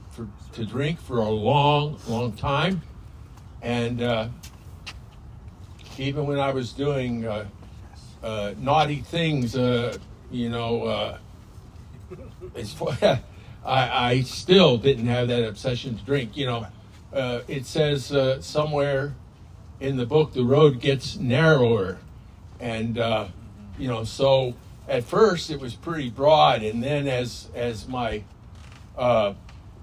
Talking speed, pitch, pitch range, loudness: 125 wpm, 120 Hz, 105-135 Hz, -24 LUFS